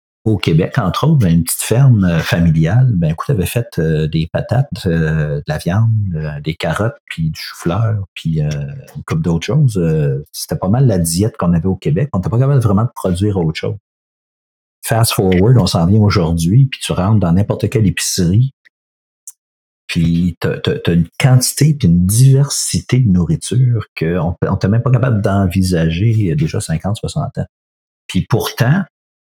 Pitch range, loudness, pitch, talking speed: 85-120 Hz, -15 LUFS, 95 Hz, 185 wpm